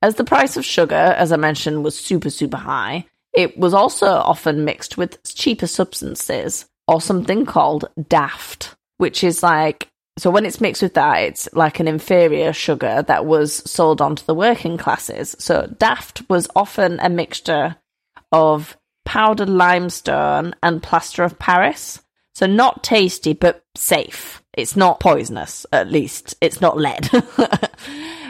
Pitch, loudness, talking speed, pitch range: 175 Hz, -17 LUFS, 150 wpm, 155-205 Hz